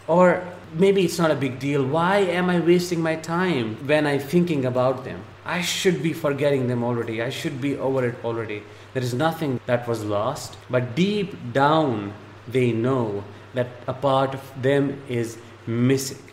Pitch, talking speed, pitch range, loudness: 135 Hz, 175 wpm, 120-160 Hz, -23 LUFS